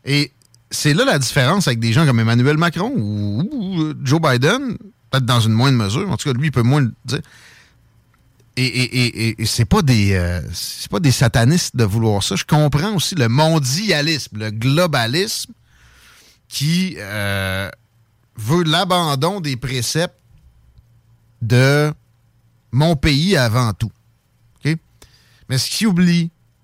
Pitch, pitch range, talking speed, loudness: 125 Hz, 115-155 Hz, 150 wpm, -17 LUFS